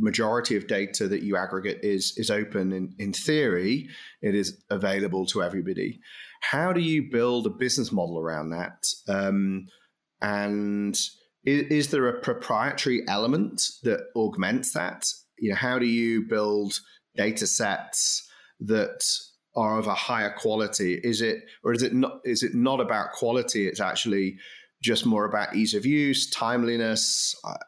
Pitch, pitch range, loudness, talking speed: 110 Hz, 100-130 Hz, -26 LUFS, 155 wpm